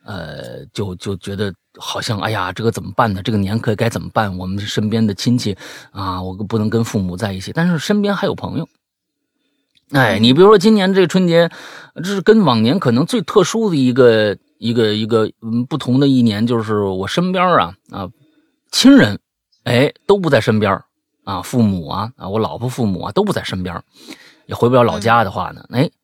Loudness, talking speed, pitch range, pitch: -16 LUFS, 280 characters per minute, 100-155 Hz, 115 Hz